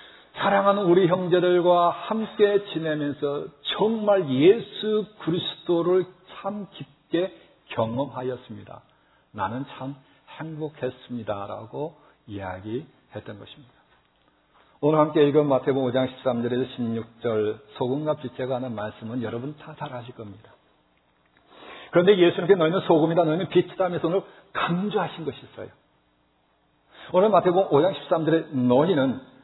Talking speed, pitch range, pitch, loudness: 275 characters per minute, 125-180 Hz, 150 Hz, -24 LUFS